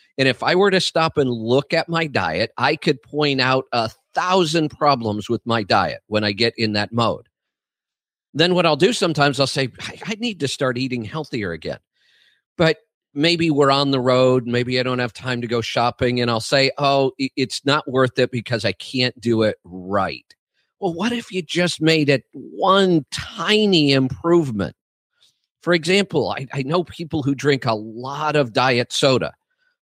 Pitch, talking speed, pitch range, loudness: 140 Hz, 185 wpm, 125-165 Hz, -19 LUFS